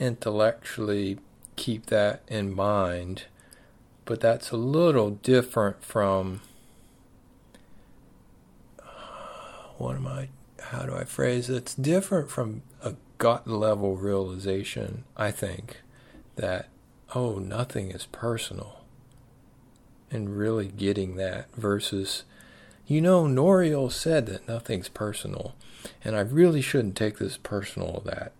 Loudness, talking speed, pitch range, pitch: -27 LUFS, 115 wpm, 100-130 Hz, 115 Hz